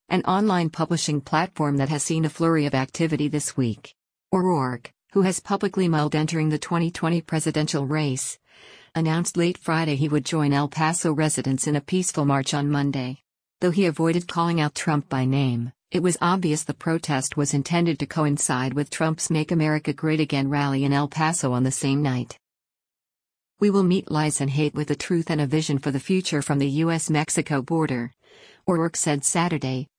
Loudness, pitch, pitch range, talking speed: -23 LUFS, 155 Hz, 140-165 Hz, 185 wpm